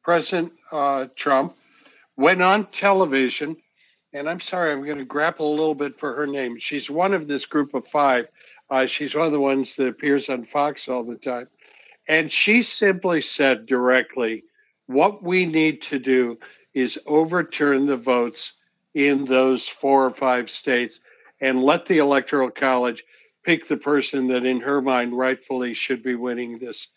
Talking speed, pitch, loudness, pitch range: 170 wpm, 140 Hz, -21 LUFS, 130-155 Hz